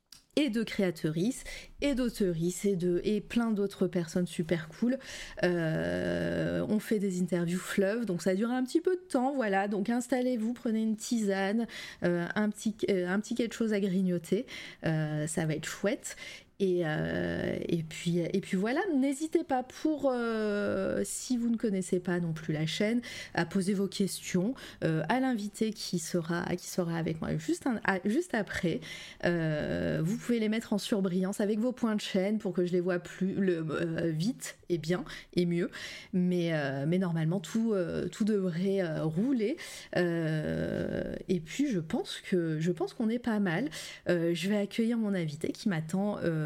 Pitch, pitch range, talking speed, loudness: 195 Hz, 175-225 Hz, 185 wpm, -31 LUFS